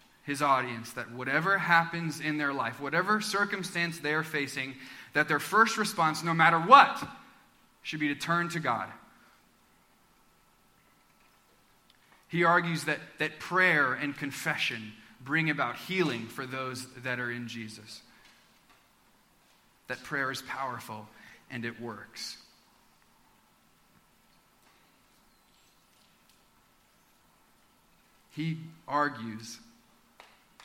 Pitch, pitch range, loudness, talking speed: 150 Hz, 130-170 Hz, -29 LUFS, 100 wpm